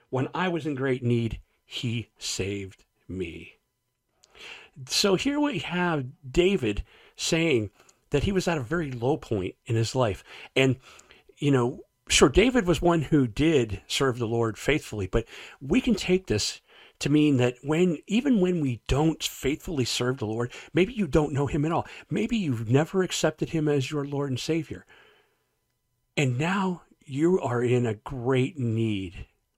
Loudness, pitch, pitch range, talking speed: -26 LUFS, 140 Hz, 120-170 Hz, 165 wpm